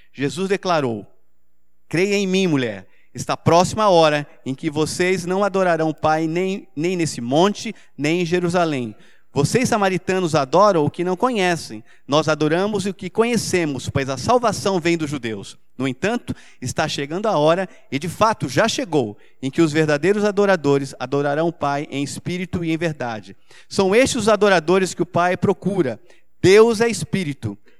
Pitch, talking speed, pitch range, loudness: 170 Hz, 165 wpm, 140-190 Hz, -19 LUFS